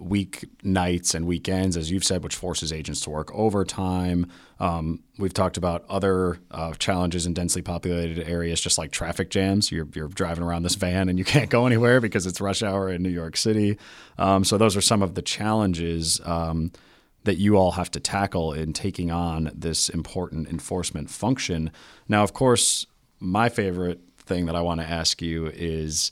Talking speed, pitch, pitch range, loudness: 190 wpm, 90 Hz, 85-95 Hz, -24 LUFS